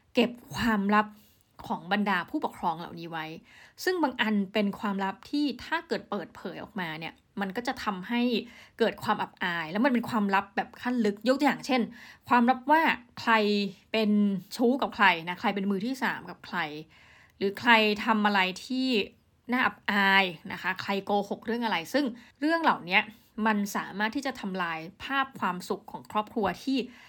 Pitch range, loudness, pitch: 195-245 Hz, -28 LUFS, 215 Hz